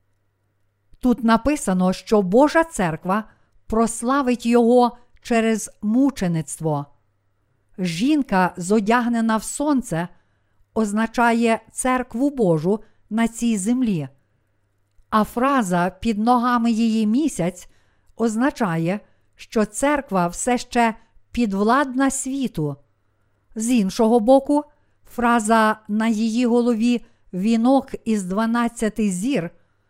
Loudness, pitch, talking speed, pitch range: -20 LUFS, 225 Hz, 85 wpm, 180-240 Hz